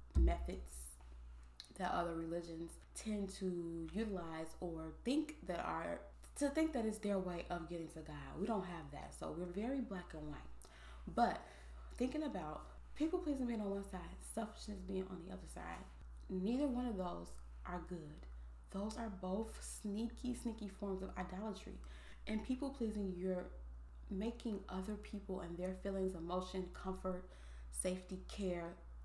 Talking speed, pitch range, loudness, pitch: 155 wpm, 150-210 Hz, -44 LUFS, 185 Hz